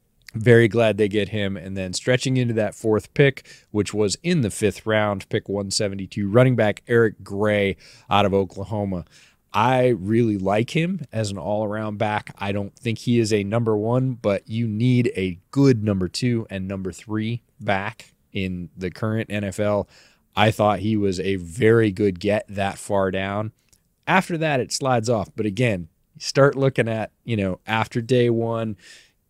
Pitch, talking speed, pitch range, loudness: 110 Hz, 175 wpm, 100-120 Hz, -22 LUFS